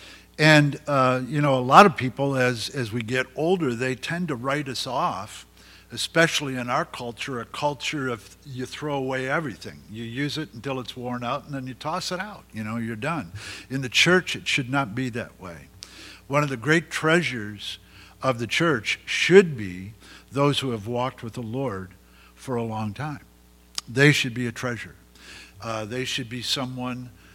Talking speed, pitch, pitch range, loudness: 190 wpm, 130 Hz, 115-145 Hz, -24 LUFS